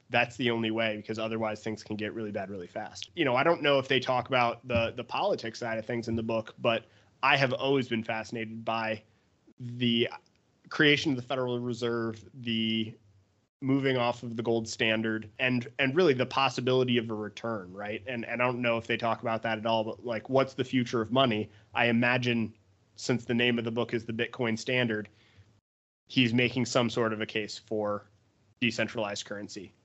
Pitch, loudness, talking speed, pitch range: 115 Hz, -29 LUFS, 205 wpm, 110-125 Hz